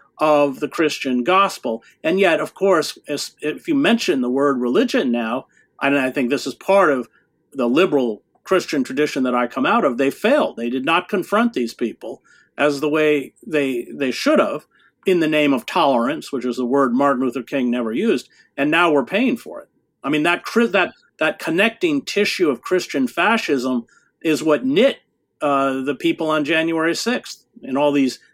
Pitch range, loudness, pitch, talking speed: 130-180 Hz, -19 LUFS, 150 Hz, 190 wpm